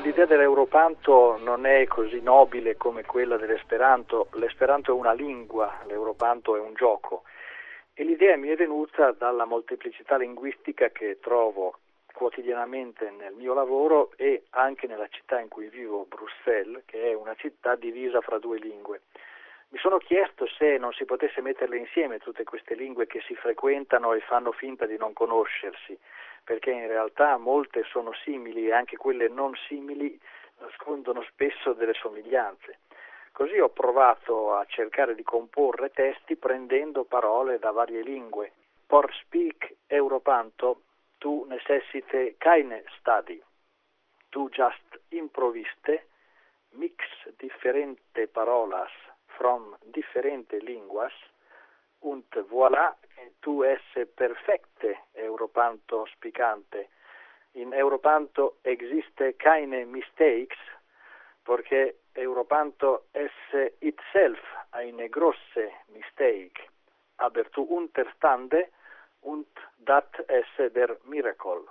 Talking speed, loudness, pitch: 115 wpm, -26 LUFS, 160 Hz